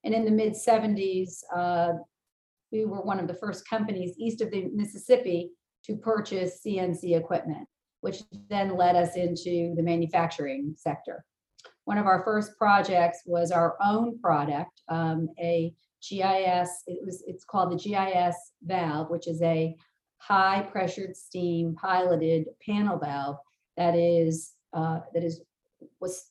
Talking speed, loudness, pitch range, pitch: 145 wpm, -28 LUFS, 170-200 Hz, 180 Hz